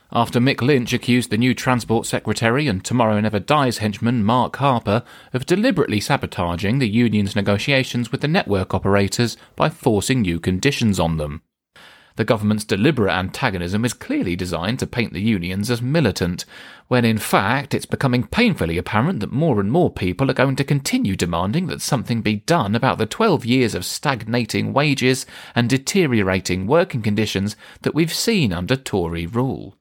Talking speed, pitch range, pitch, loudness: 165 wpm, 100-130 Hz, 115 Hz, -20 LUFS